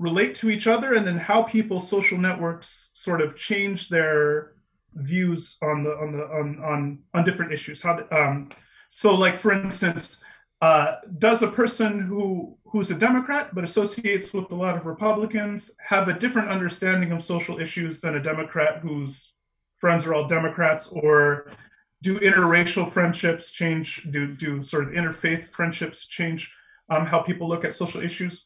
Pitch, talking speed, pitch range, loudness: 170 Hz, 170 wpm, 155-195 Hz, -23 LUFS